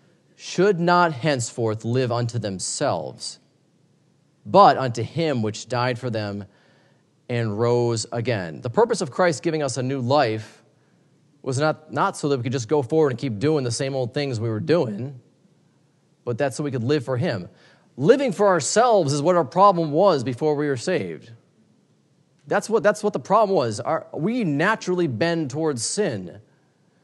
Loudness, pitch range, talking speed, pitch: -22 LUFS, 120-170 Hz, 175 wpm, 145 Hz